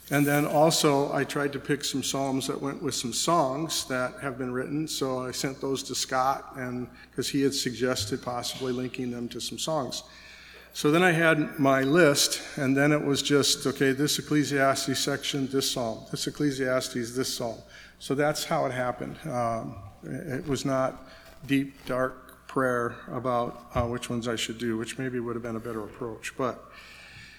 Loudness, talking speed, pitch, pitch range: -27 LUFS, 185 wpm, 135 Hz, 125-140 Hz